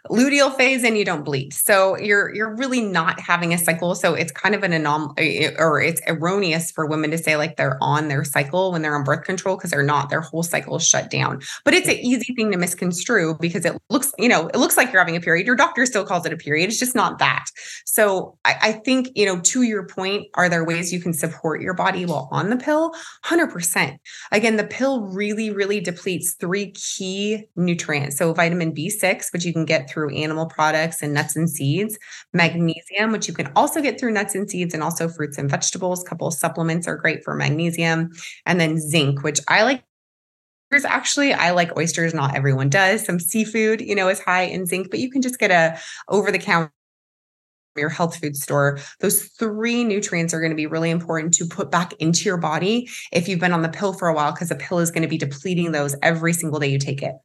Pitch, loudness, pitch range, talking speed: 175 Hz, -20 LUFS, 160-205 Hz, 230 wpm